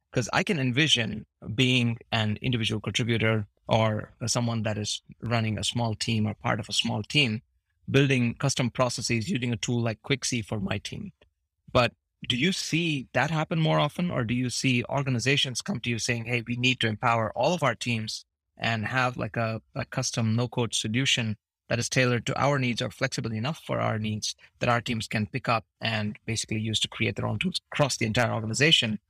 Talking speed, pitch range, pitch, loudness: 200 wpm, 110-130 Hz, 120 Hz, -27 LUFS